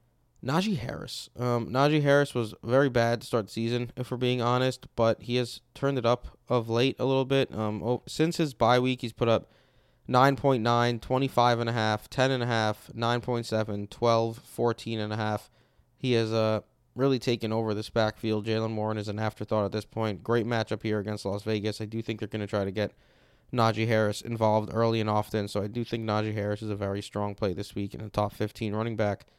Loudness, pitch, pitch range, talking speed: -28 LUFS, 115 Hz, 105-120 Hz, 200 wpm